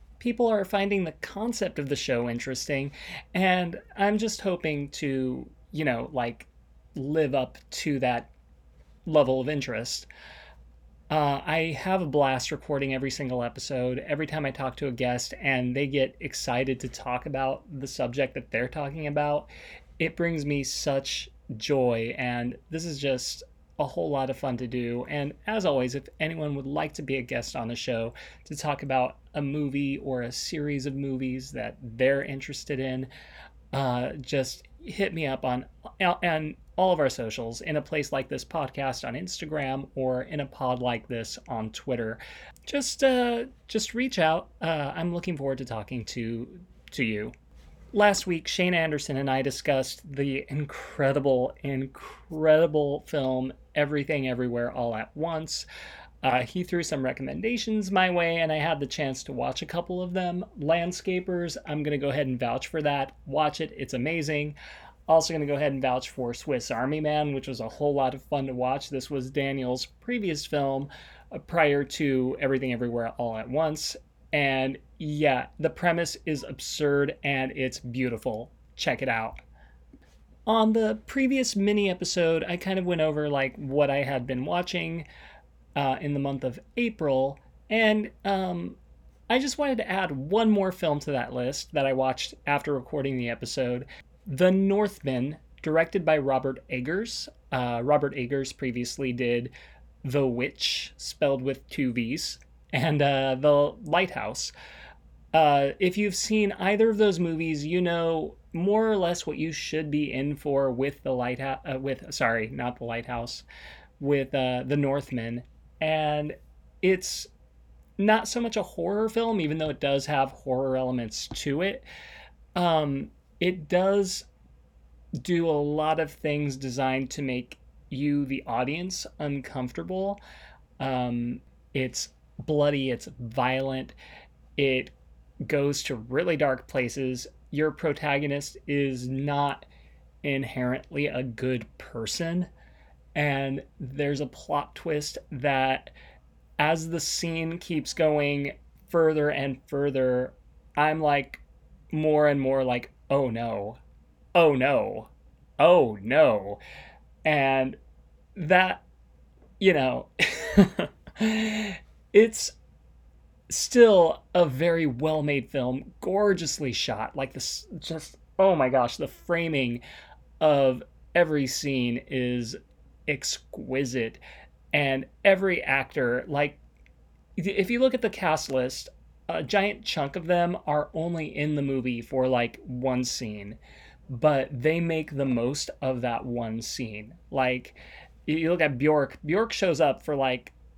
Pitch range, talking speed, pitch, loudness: 125-160 Hz, 150 wpm, 140 Hz, -27 LUFS